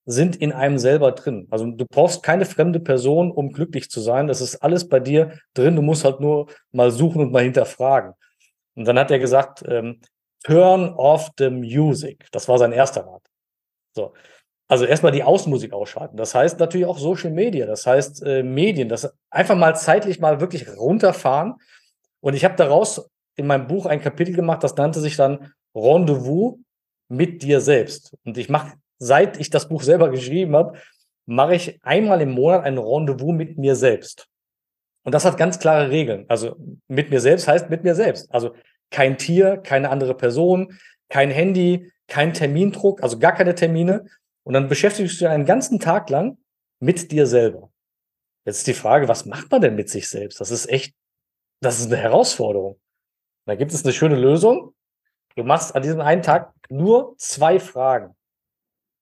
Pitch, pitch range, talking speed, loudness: 150 Hz, 130-175 Hz, 180 wpm, -18 LUFS